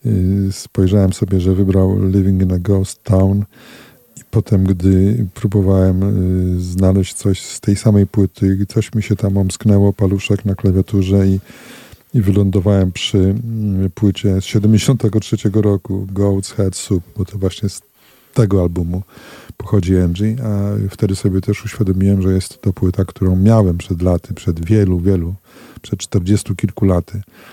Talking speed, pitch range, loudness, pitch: 145 wpm, 95-105 Hz, -16 LUFS, 100 Hz